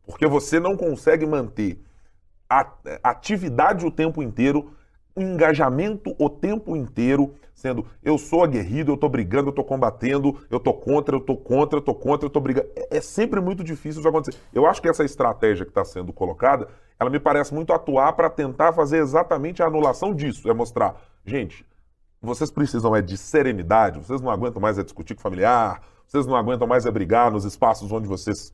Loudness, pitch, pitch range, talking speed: -22 LUFS, 145 Hz, 120-160 Hz, 190 wpm